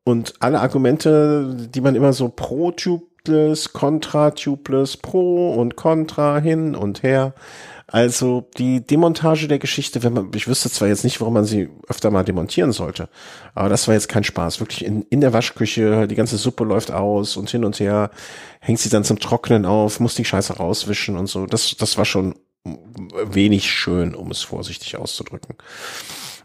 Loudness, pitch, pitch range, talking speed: -19 LUFS, 120 Hz, 105-140 Hz, 170 wpm